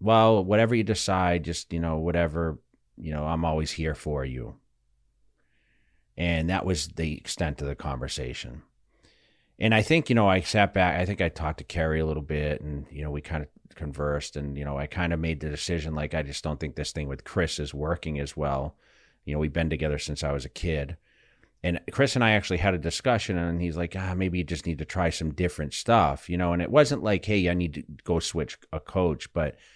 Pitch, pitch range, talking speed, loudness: 80 Hz, 75-90 Hz, 230 wpm, -27 LUFS